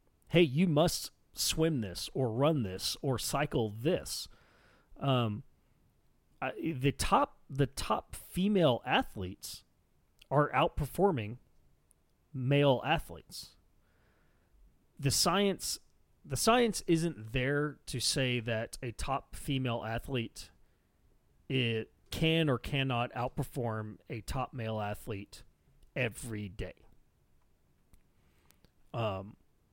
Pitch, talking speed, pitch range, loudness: 120 Hz, 95 wpm, 95-145 Hz, -33 LUFS